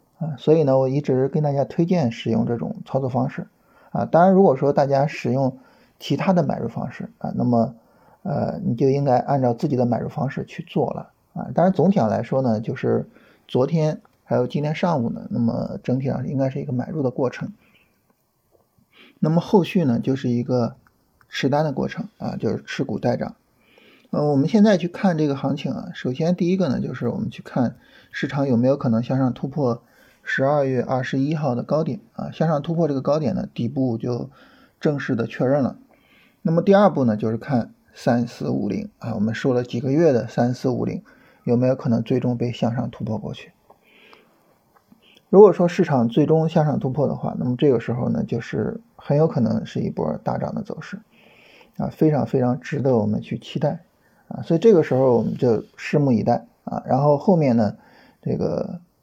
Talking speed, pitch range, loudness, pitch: 290 characters per minute, 125-170 Hz, -21 LUFS, 140 Hz